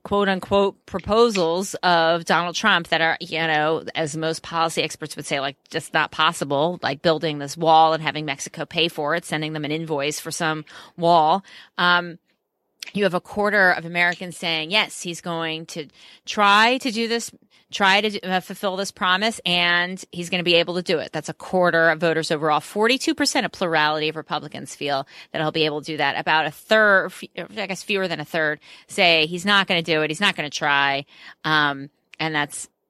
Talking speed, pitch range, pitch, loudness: 205 wpm, 155-190 Hz, 170 Hz, -21 LUFS